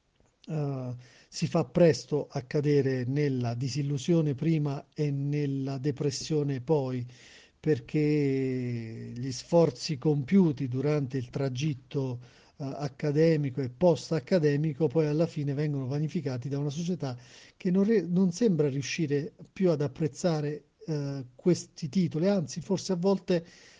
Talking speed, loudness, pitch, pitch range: 120 wpm, -29 LUFS, 150 Hz, 135-165 Hz